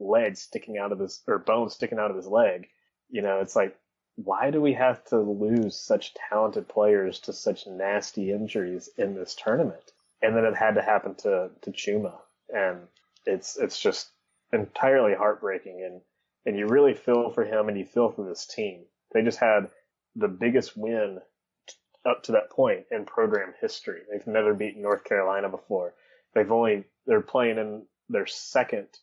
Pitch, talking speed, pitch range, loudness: 110 Hz, 180 wpm, 100-145 Hz, -26 LUFS